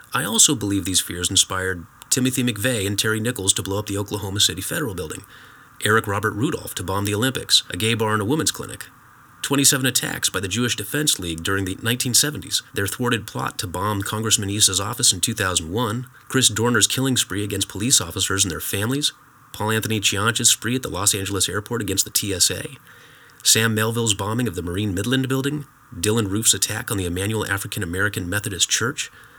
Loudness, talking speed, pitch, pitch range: -20 LUFS, 190 wpm, 110 Hz, 100-120 Hz